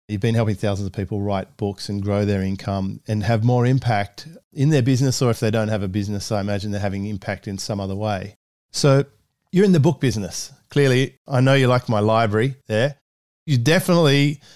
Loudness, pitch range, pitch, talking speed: -20 LUFS, 100-135 Hz, 110 Hz, 210 wpm